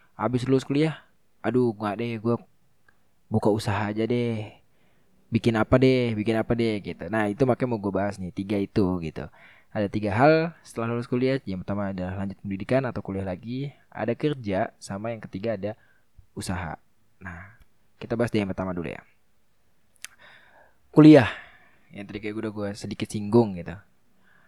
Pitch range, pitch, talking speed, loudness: 100-120 Hz, 110 Hz, 165 wpm, -25 LUFS